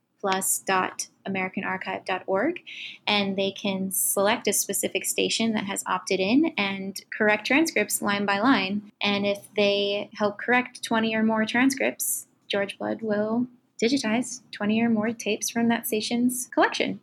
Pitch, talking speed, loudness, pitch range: 210 Hz, 135 wpm, -25 LUFS, 200-235 Hz